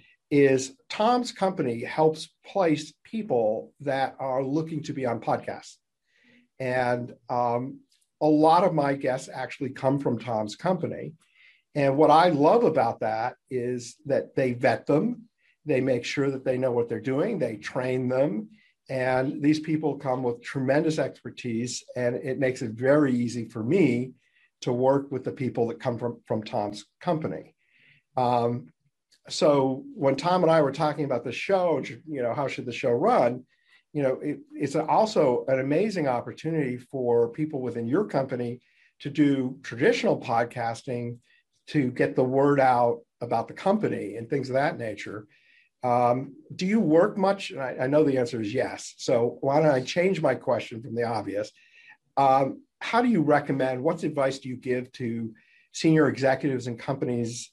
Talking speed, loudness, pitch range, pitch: 170 wpm, -26 LUFS, 125-155 Hz, 135 Hz